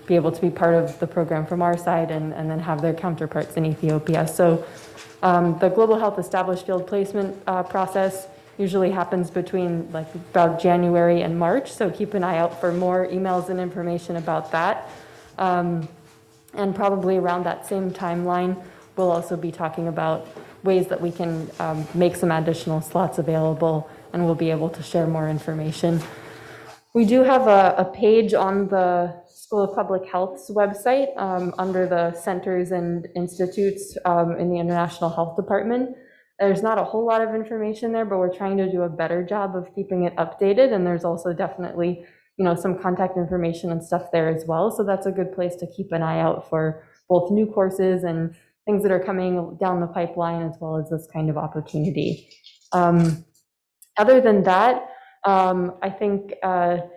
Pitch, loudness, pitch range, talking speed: 180 Hz, -22 LUFS, 165-190 Hz, 185 wpm